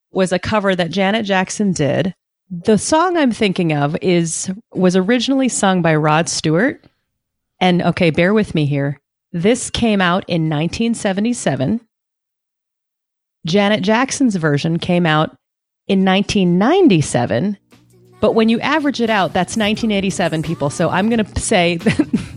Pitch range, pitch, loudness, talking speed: 165-220 Hz, 190 Hz, -16 LUFS, 140 wpm